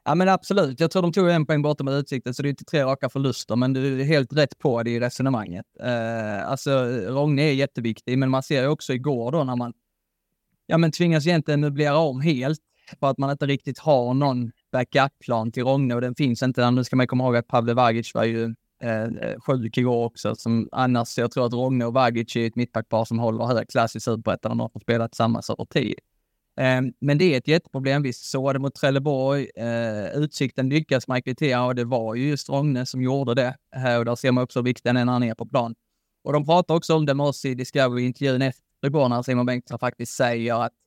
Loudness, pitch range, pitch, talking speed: -23 LUFS, 120-140 Hz, 130 Hz, 225 wpm